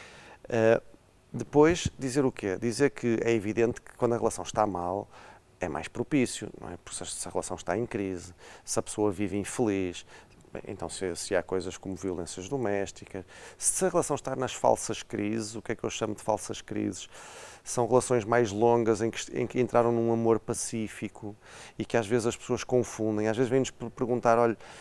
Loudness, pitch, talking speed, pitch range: -29 LUFS, 115 Hz, 195 wpm, 100-120 Hz